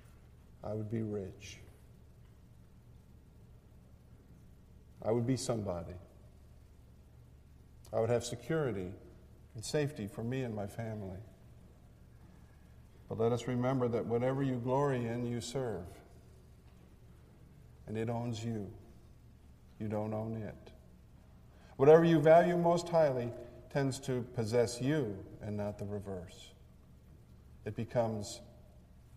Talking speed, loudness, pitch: 110 wpm, -34 LUFS, 105 Hz